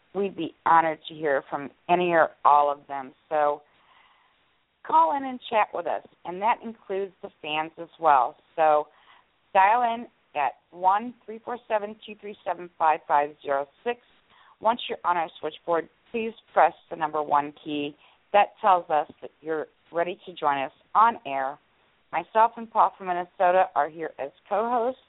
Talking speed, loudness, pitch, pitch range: 155 wpm, -25 LUFS, 175 Hz, 150-215 Hz